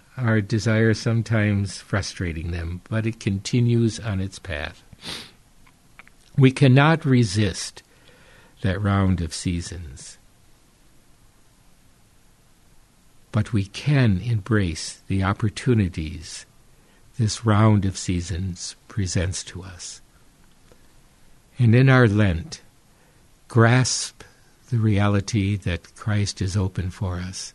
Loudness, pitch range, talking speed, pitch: -22 LUFS, 95-115 Hz, 95 wpm, 100 Hz